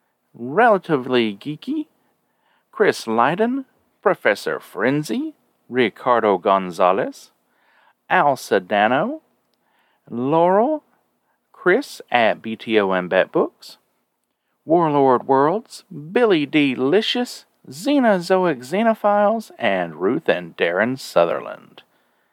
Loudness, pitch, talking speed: -19 LUFS, 175 Hz, 75 wpm